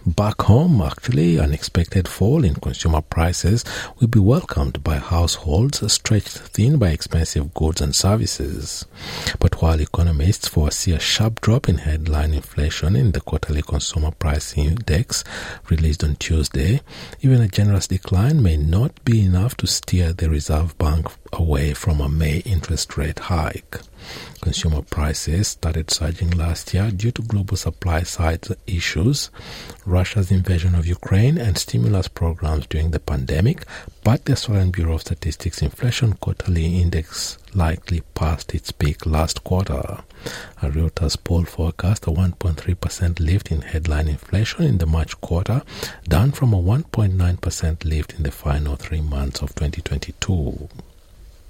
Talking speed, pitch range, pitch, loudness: 140 wpm, 80-100 Hz, 85 Hz, -20 LUFS